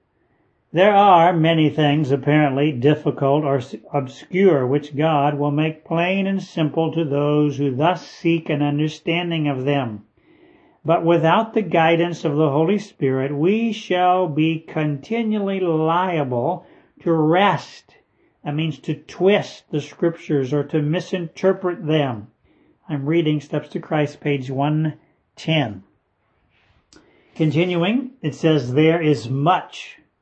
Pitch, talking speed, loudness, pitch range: 155 Hz, 125 wpm, -20 LUFS, 145-175 Hz